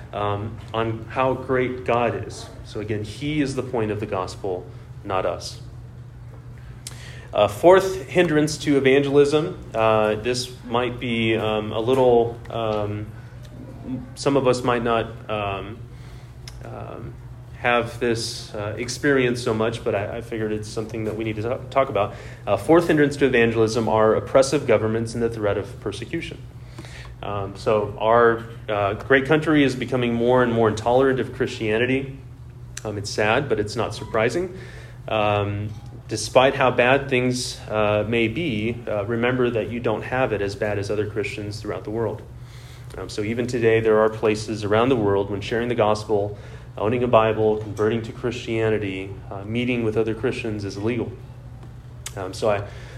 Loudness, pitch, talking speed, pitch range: -22 LUFS, 115 Hz, 160 wpm, 110-125 Hz